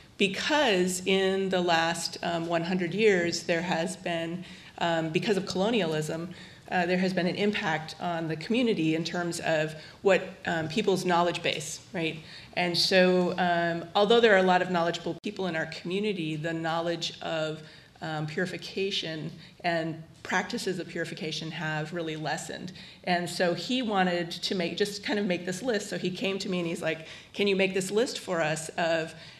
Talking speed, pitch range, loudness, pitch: 175 wpm, 165-190 Hz, -28 LUFS, 175 Hz